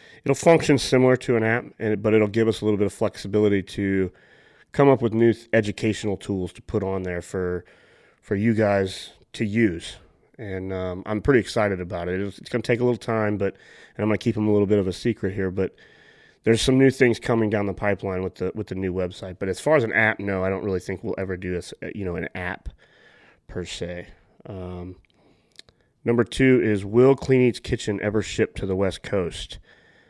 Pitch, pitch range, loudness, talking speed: 105 Hz, 95-115 Hz, -23 LUFS, 220 wpm